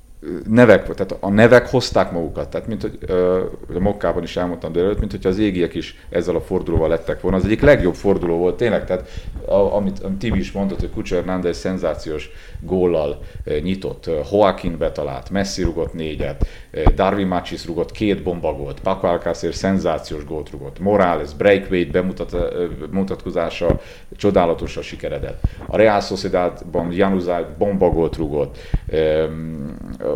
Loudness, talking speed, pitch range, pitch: -19 LUFS, 155 wpm, 85-100 Hz, 90 Hz